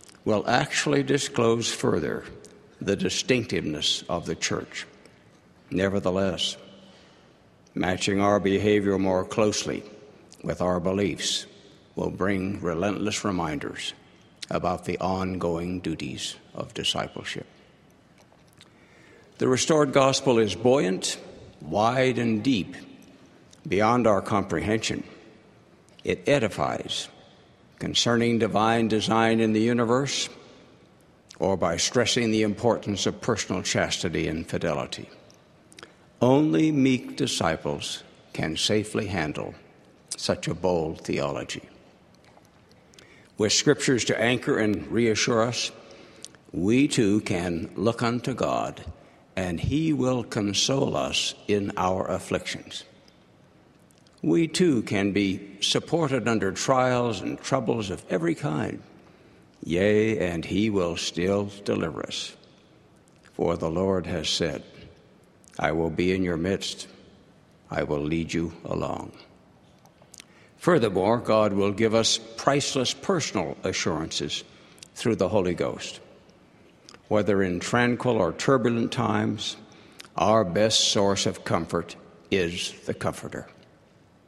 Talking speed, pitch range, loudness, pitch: 105 wpm, 95-120 Hz, -25 LUFS, 105 Hz